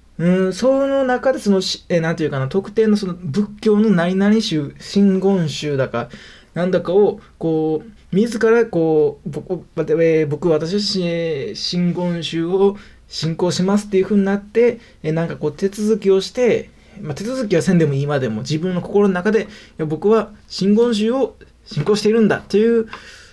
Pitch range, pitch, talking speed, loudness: 165-215 Hz, 190 Hz, 305 characters per minute, -18 LUFS